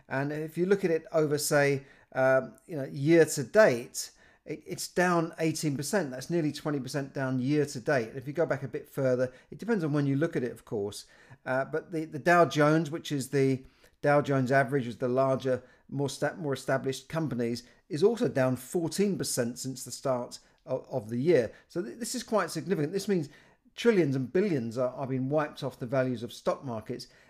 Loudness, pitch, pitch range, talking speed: -29 LUFS, 145 Hz, 130-160 Hz, 215 wpm